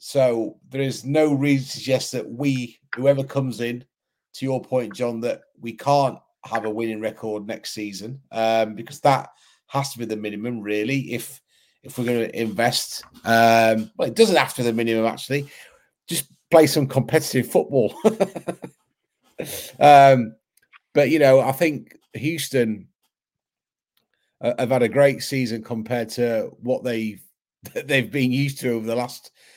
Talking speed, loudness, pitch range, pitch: 160 wpm, -21 LUFS, 115-135 Hz, 125 Hz